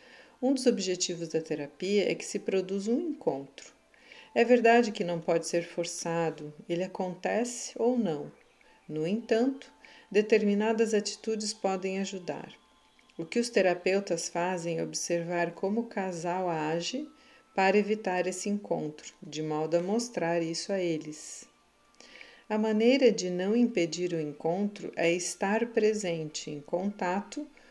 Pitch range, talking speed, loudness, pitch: 170-225 Hz, 135 wpm, -30 LUFS, 190 Hz